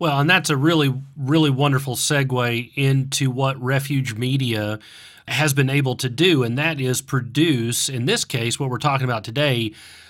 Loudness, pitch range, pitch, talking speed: -20 LUFS, 125-145 Hz, 135 Hz, 170 wpm